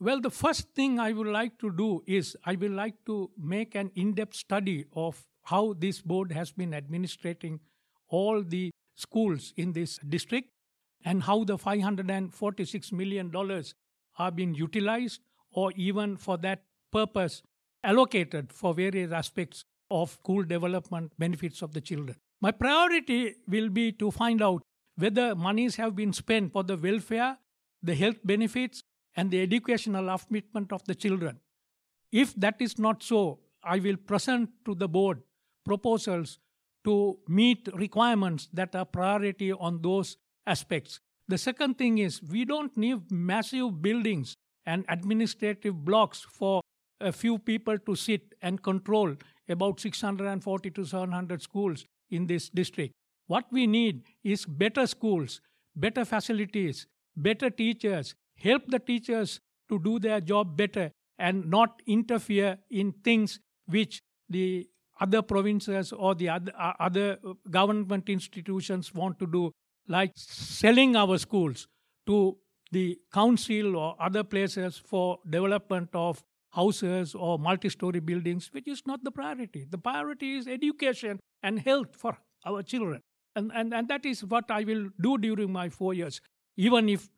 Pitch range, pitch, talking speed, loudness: 180-220 Hz, 195 Hz, 145 wpm, -29 LUFS